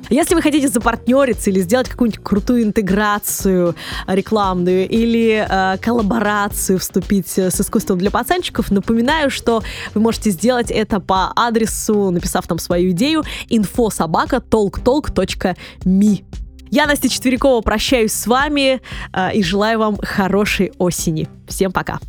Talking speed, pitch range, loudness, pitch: 120 wpm, 190-235 Hz, -16 LUFS, 210 Hz